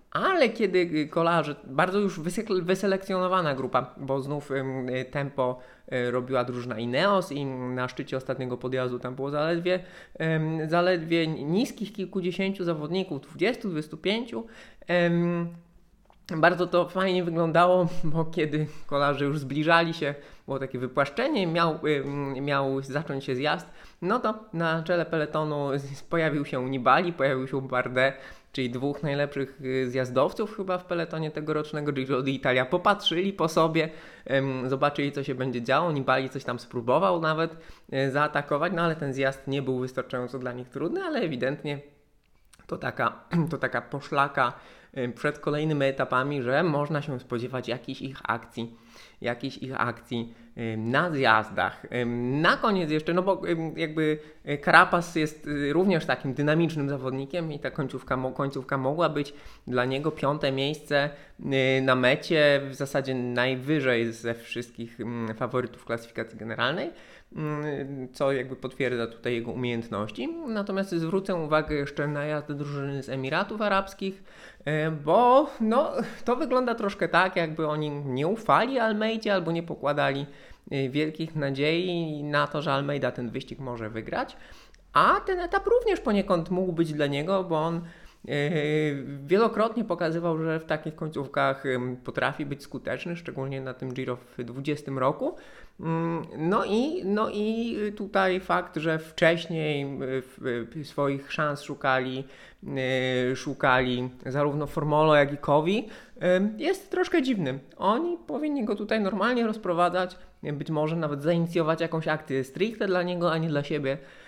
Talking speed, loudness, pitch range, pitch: 135 wpm, -27 LUFS, 135-175 Hz, 150 Hz